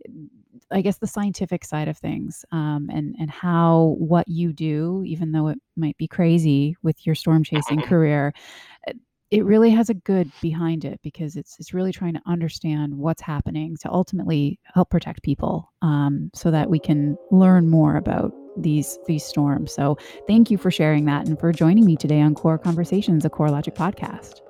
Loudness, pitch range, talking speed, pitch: -21 LUFS, 150-180 Hz, 185 wpm, 165 Hz